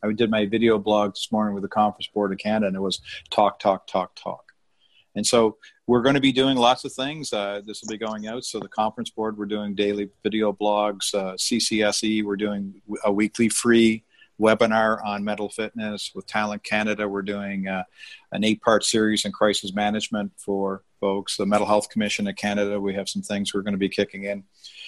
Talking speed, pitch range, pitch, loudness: 210 wpm, 100-110 Hz, 105 Hz, -23 LUFS